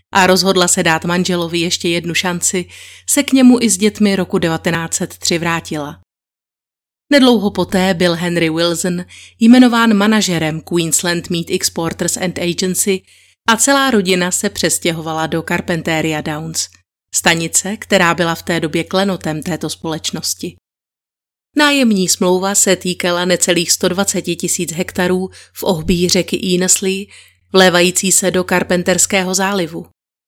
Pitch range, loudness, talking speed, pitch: 170-190 Hz, -14 LUFS, 125 wpm, 180 Hz